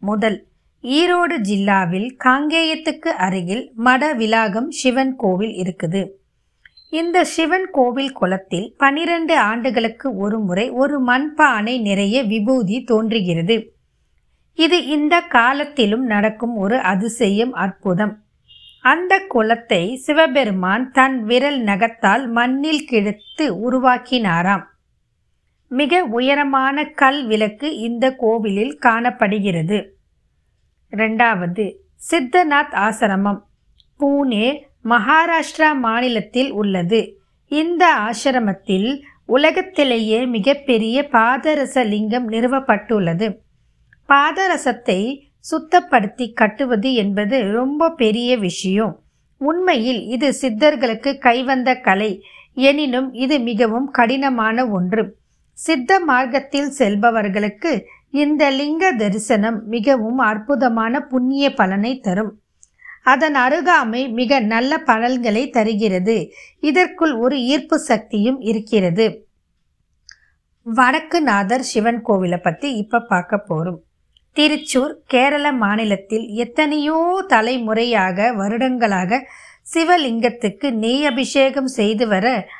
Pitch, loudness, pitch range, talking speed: 245 Hz, -17 LUFS, 215-280 Hz, 85 wpm